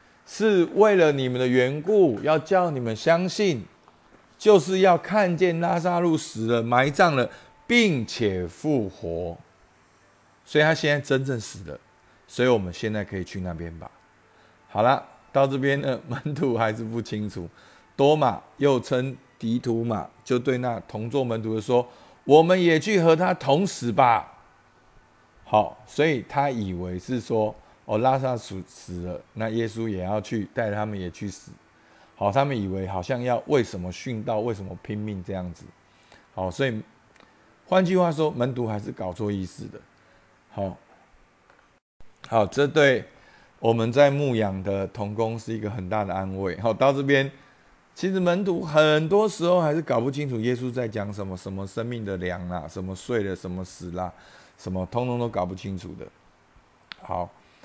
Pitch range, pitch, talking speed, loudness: 100-140 Hz, 115 Hz, 235 characters per minute, -24 LUFS